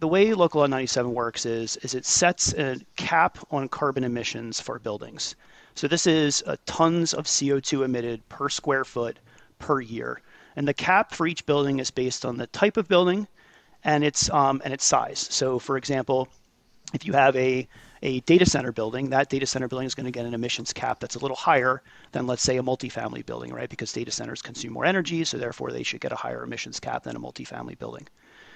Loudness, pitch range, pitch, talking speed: -25 LUFS, 125-150 Hz, 135 Hz, 210 wpm